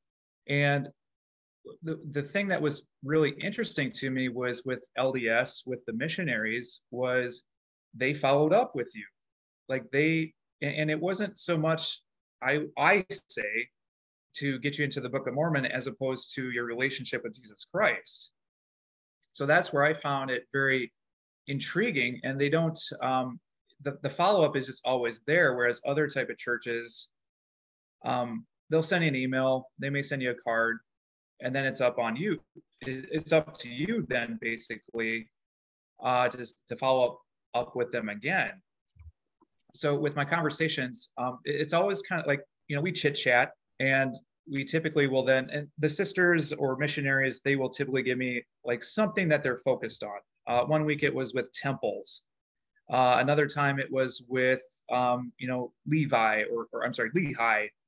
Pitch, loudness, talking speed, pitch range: 130 Hz, -29 LUFS, 170 wpm, 120-150 Hz